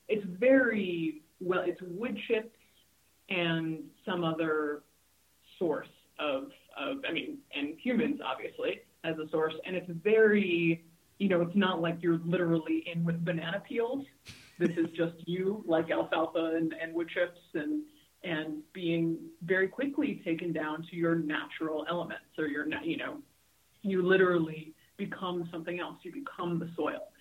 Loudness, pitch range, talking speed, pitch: -32 LUFS, 165-220 Hz, 150 wpm, 175 Hz